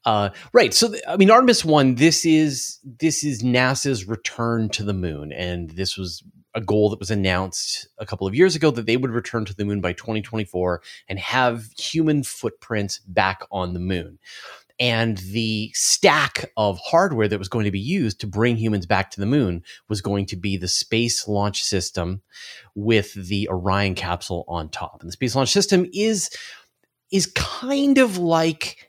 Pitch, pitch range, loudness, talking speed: 110 Hz, 95-135 Hz, -21 LUFS, 185 wpm